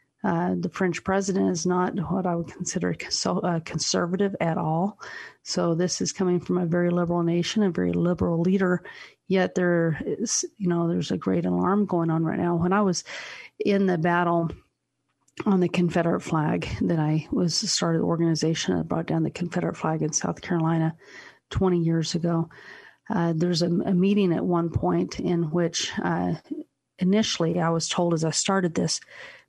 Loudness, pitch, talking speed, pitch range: -25 LUFS, 175 Hz, 180 wpm, 165-185 Hz